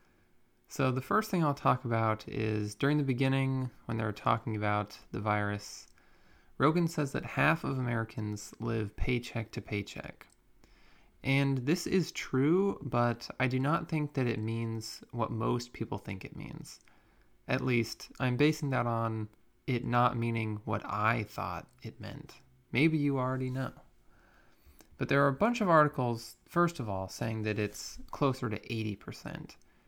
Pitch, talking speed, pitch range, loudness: 120 Hz, 160 wpm, 110-135 Hz, -32 LUFS